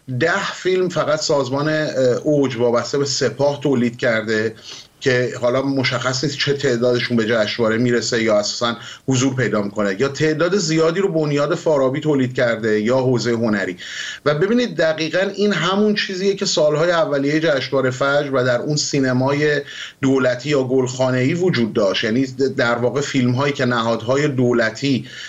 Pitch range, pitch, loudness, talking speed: 120-150 Hz, 135 Hz, -18 LUFS, 145 wpm